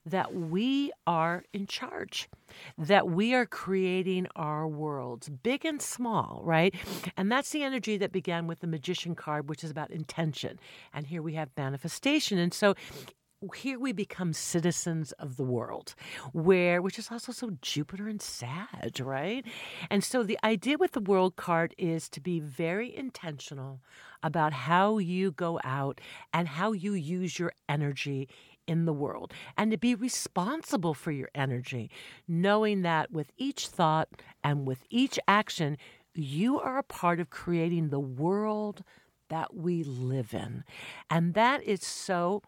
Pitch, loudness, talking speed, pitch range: 175 Hz, -31 LUFS, 155 wpm, 155-205 Hz